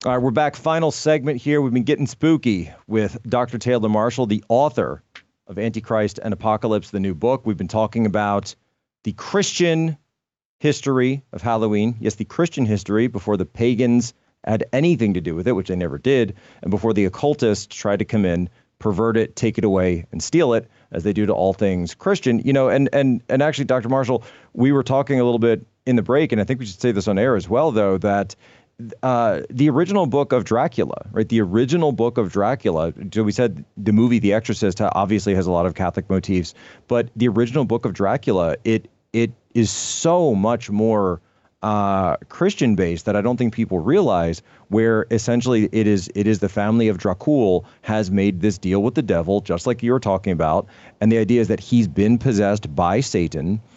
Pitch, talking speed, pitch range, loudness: 110 Hz, 205 wpm, 100-125 Hz, -20 LUFS